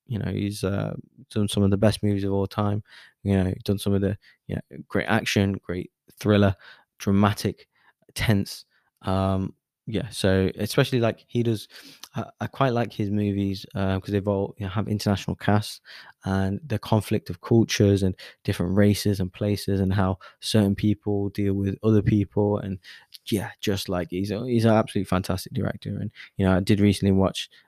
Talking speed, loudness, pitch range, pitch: 185 wpm, -25 LUFS, 95-105 Hz, 100 Hz